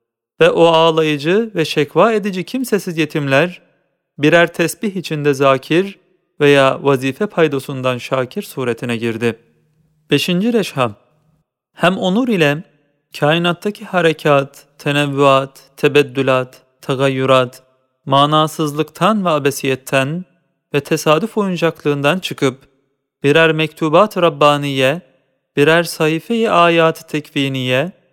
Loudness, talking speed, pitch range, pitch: -15 LUFS, 90 wpm, 135-170 Hz, 150 Hz